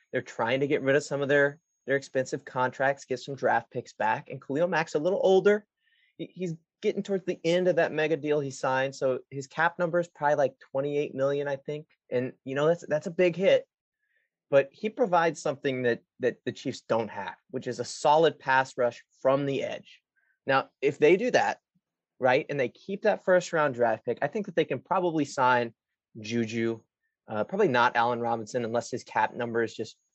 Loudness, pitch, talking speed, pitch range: -28 LUFS, 145 Hz, 210 wpm, 130-175 Hz